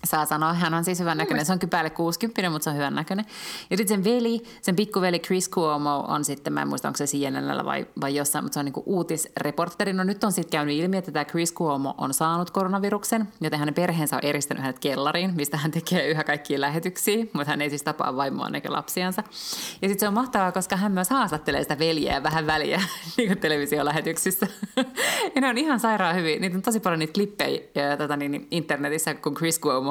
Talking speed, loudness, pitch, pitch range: 215 wpm, -25 LUFS, 165 Hz, 150-195 Hz